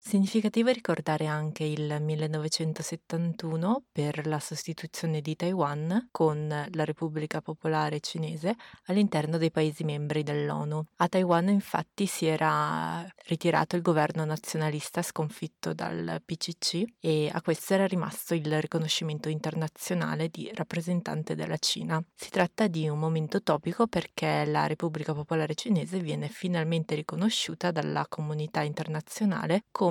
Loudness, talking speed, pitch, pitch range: -30 LUFS, 125 wpm, 160 Hz, 155-175 Hz